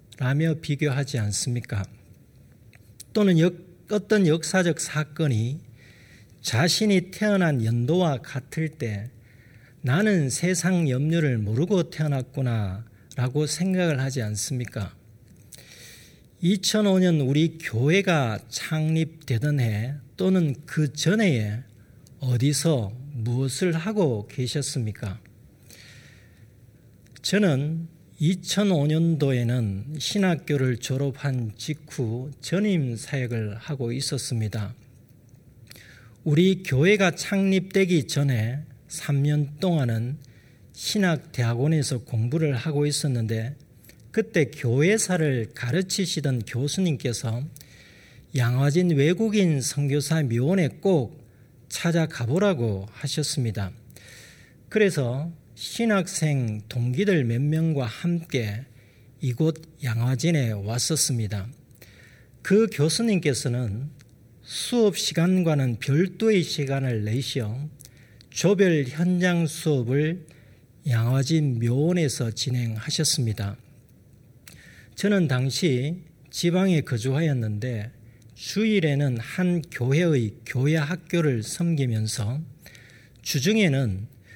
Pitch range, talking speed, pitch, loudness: 120-165 Hz, 205 characters per minute, 140 Hz, -24 LUFS